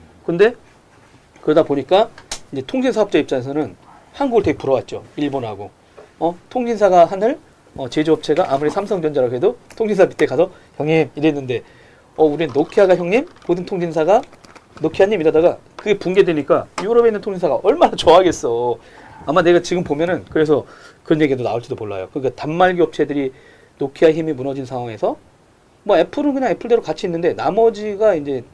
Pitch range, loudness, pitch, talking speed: 145-200 Hz, -17 LUFS, 160 Hz, 390 characters per minute